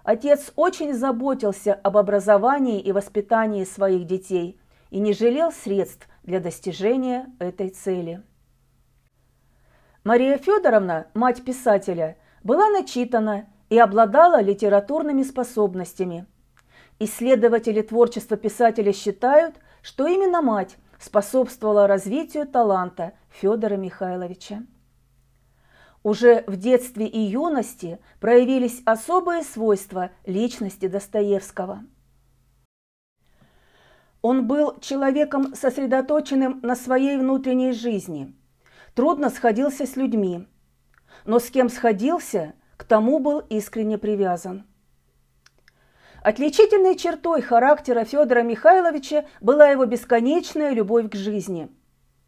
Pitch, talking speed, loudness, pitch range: 220 Hz, 95 wpm, -21 LUFS, 190-260 Hz